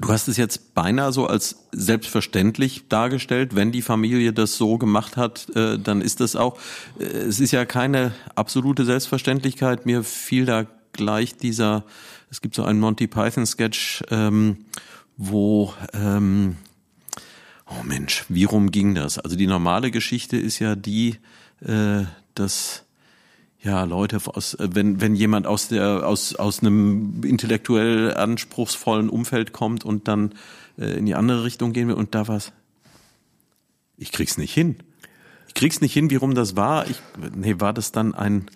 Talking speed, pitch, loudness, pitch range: 150 wpm, 110 Hz, -22 LUFS, 105-120 Hz